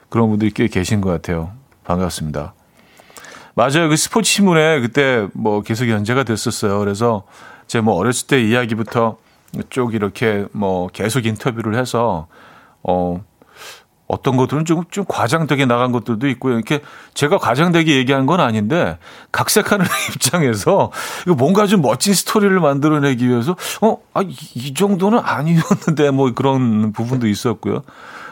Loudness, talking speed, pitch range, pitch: -17 LUFS, 310 characters per minute, 110-155 Hz, 125 Hz